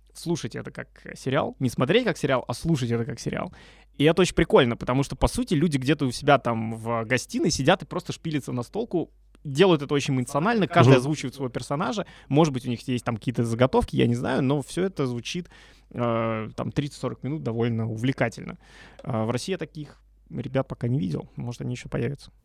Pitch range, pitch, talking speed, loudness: 125-160 Hz, 135 Hz, 200 wpm, -25 LUFS